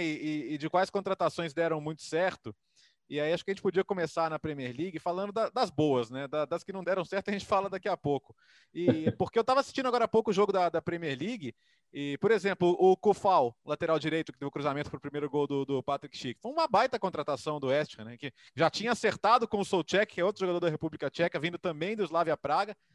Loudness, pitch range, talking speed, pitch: -30 LUFS, 150-195 Hz, 250 wpm, 170 Hz